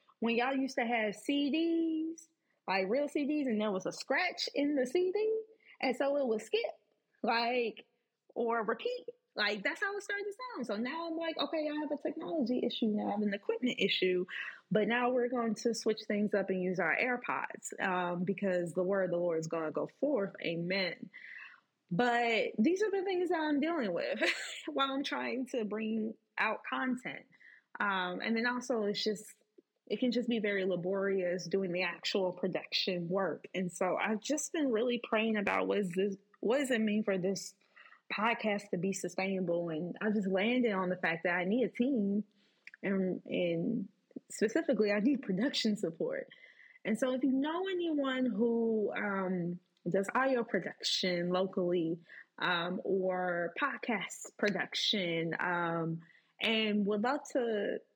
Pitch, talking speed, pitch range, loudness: 220 Hz, 170 wpm, 190-270 Hz, -34 LUFS